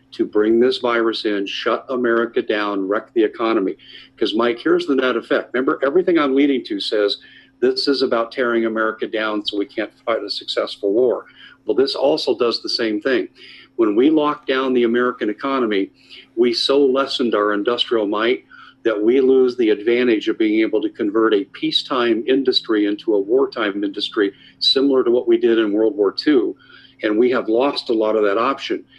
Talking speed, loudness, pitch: 190 wpm, -18 LUFS, 175 Hz